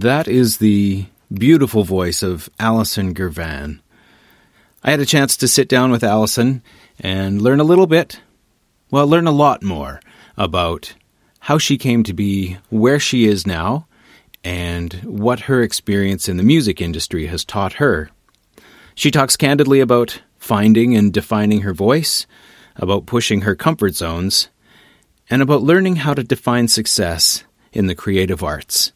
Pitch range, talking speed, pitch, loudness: 95-135 Hz, 150 wpm, 110 Hz, -16 LUFS